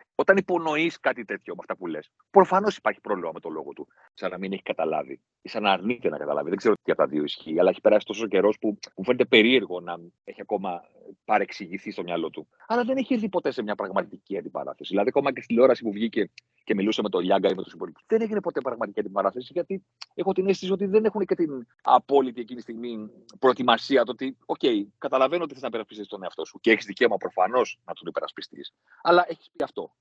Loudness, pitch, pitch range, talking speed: -25 LUFS, 140 Hz, 115-195 Hz, 230 wpm